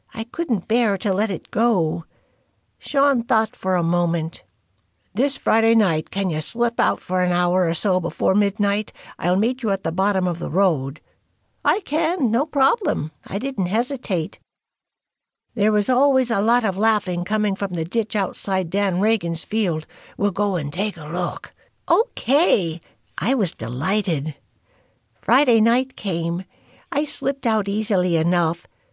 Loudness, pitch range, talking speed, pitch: -21 LUFS, 175-230 Hz, 155 wpm, 200 Hz